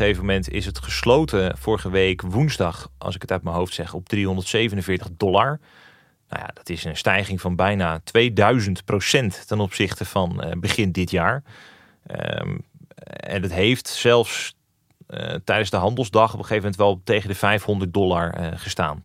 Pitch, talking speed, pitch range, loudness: 100 Hz, 165 wpm, 95-105 Hz, -22 LUFS